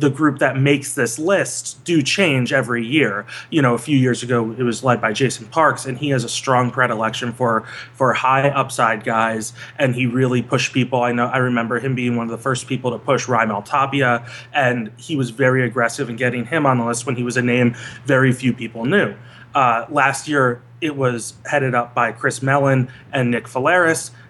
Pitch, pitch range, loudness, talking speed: 125 Hz, 120-135 Hz, -18 LUFS, 210 wpm